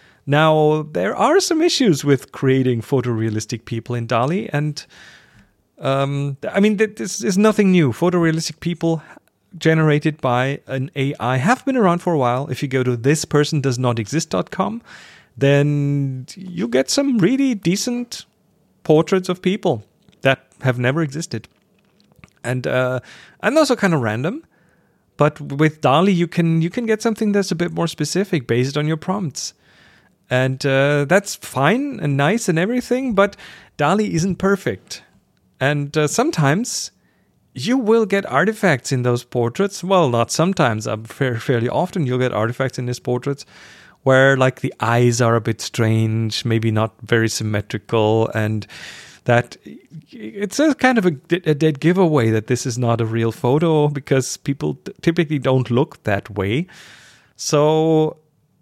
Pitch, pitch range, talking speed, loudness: 150 Hz, 125-185 Hz, 150 wpm, -19 LUFS